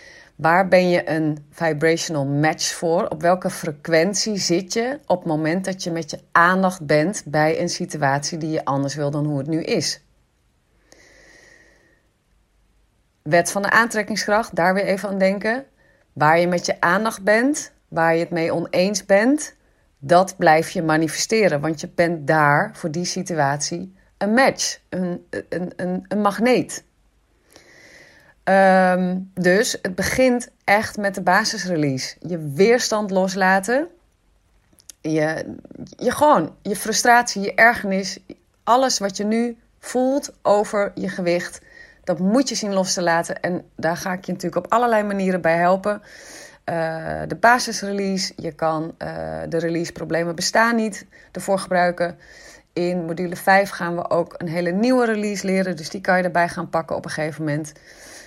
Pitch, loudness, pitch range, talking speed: 185 Hz, -20 LUFS, 165-210 Hz, 155 wpm